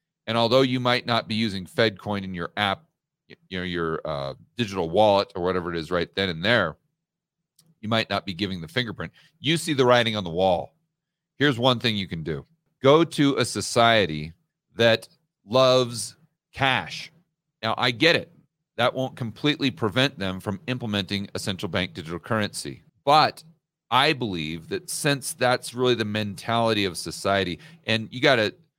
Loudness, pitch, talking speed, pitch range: -24 LUFS, 115 Hz, 170 wpm, 100-150 Hz